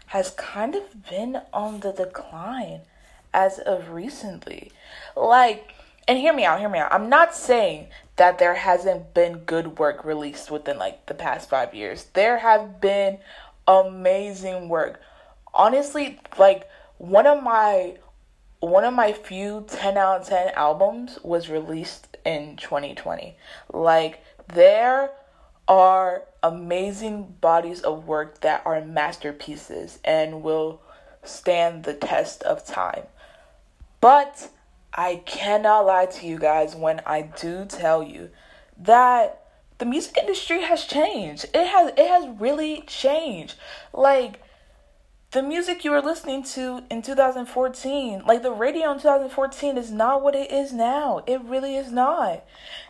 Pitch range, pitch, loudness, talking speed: 175-275 Hz, 210 Hz, -21 LUFS, 140 wpm